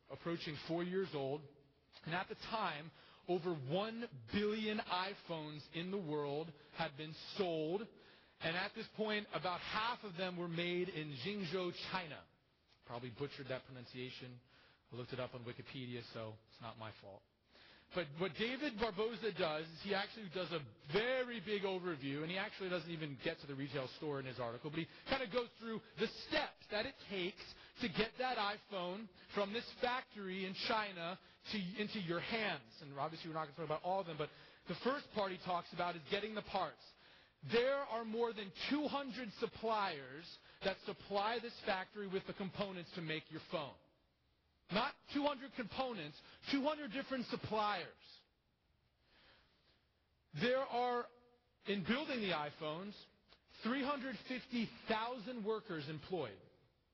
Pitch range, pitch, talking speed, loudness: 155-220 Hz, 185 Hz, 160 wpm, -42 LUFS